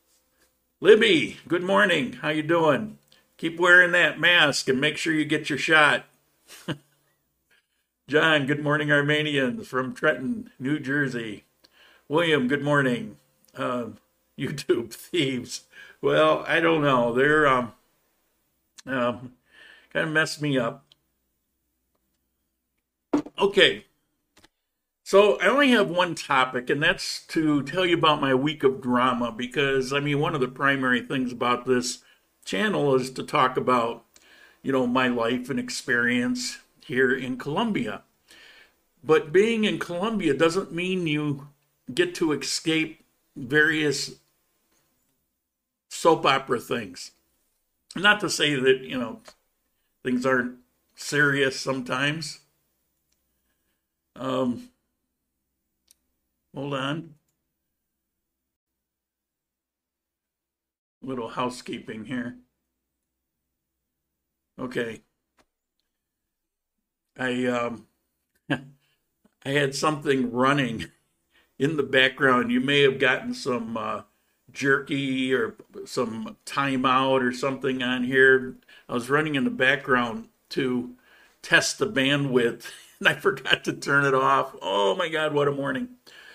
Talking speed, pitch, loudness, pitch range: 115 wpm, 135 Hz, -23 LUFS, 125-150 Hz